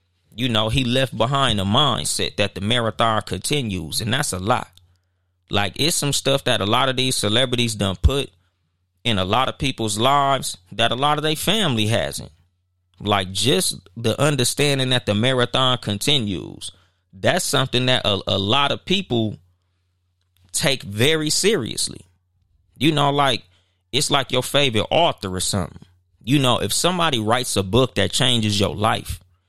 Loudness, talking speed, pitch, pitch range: -20 LUFS, 165 wpm, 110 Hz, 95-130 Hz